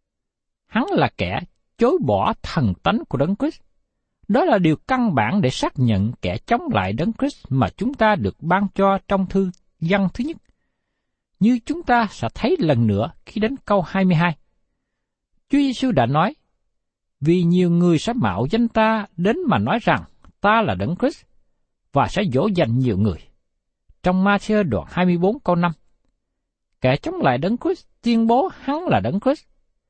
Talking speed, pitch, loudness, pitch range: 175 wpm, 195 Hz, -20 LUFS, 170-235 Hz